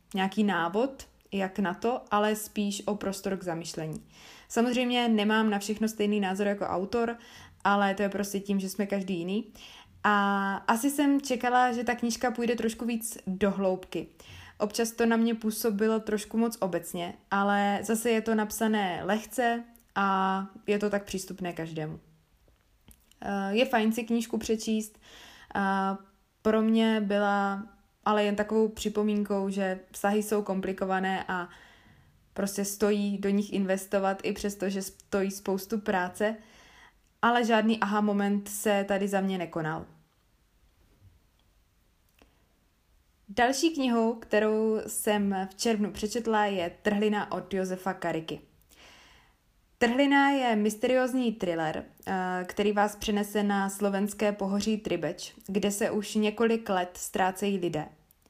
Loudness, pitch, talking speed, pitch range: -29 LUFS, 205 Hz, 130 wpm, 190-220 Hz